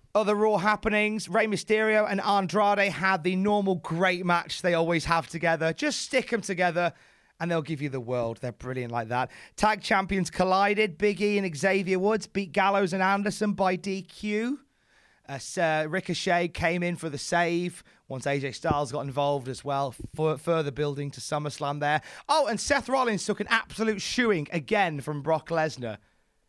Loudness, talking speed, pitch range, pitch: -27 LUFS, 175 wpm, 150-205 Hz, 180 Hz